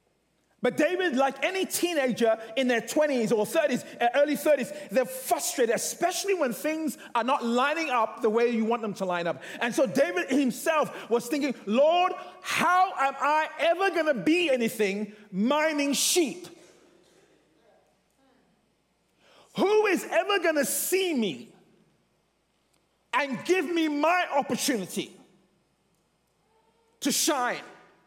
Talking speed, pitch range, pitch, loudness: 130 wpm, 235-330 Hz, 285 Hz, -26 LUFS